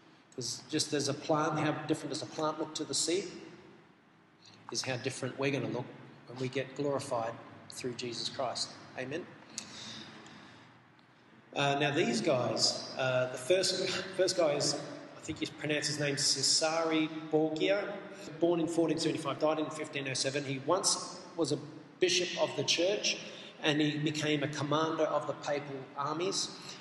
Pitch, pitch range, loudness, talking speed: 150 Hz, 140-160 Hz, -32 LUFS, 165 wpm